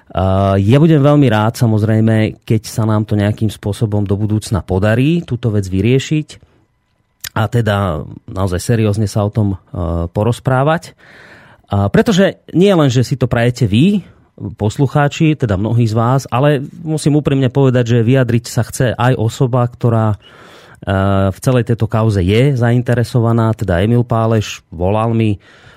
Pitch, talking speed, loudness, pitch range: 115 Hz, 140 wpm, -14 LUFS, 105-130 Hz